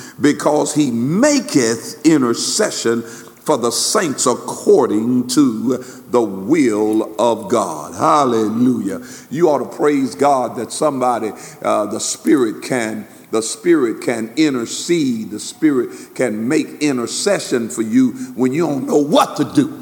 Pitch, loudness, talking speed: 155 Hz, -17 LUFS, 130 wpm